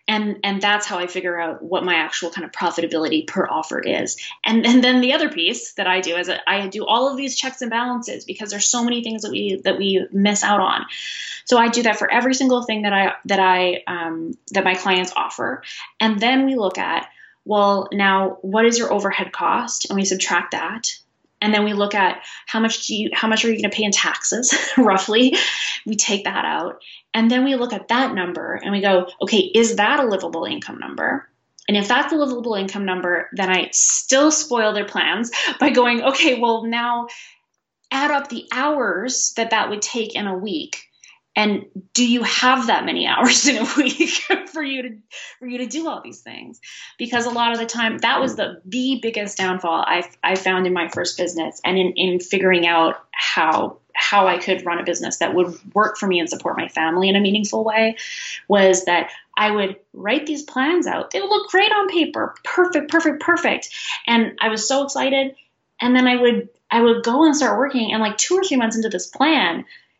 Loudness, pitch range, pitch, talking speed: -19 LUFS, 195-255 Hz, 220 Hz, 215 wpm